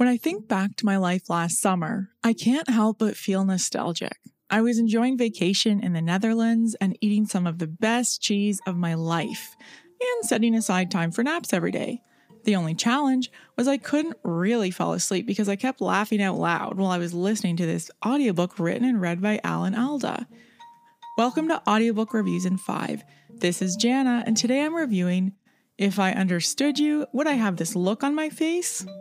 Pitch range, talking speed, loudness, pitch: 190-250 Hz, 190 wpm, -24 LUFS, 215 Hz